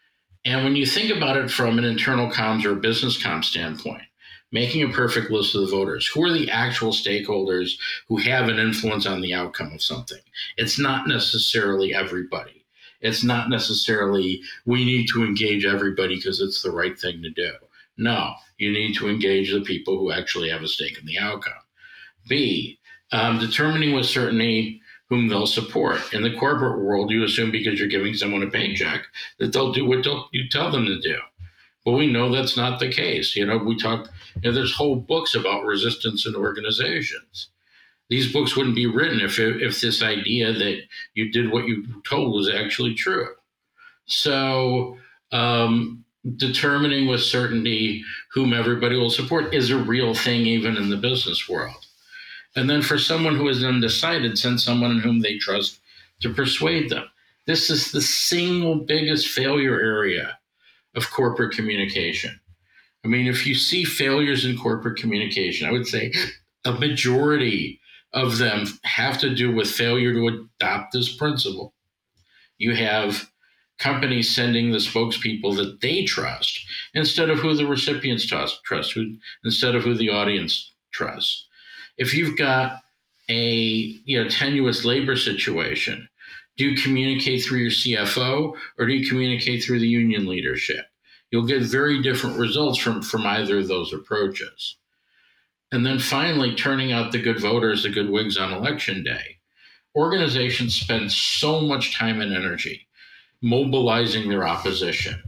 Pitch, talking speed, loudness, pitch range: 120 Hz, 165 wpm, -22 LUFS, 110-135 Hz